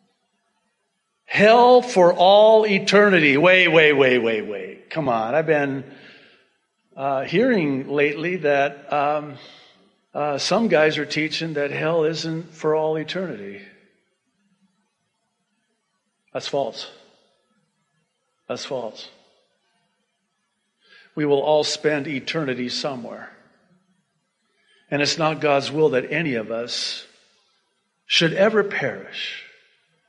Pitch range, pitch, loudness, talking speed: 145-200 Hz, 165 Hz, -19 LUFS, 100 wpm